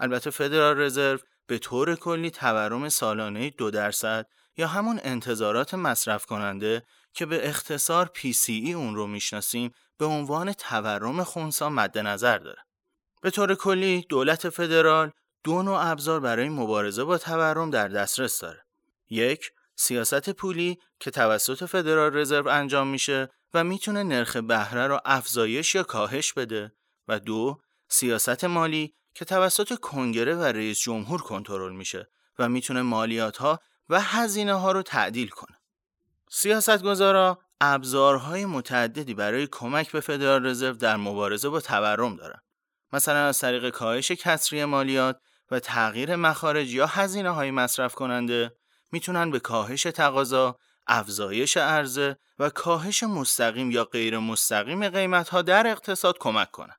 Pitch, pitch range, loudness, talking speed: 140 Hz, 120-170 Hz, -25 LUFS, 135 wpm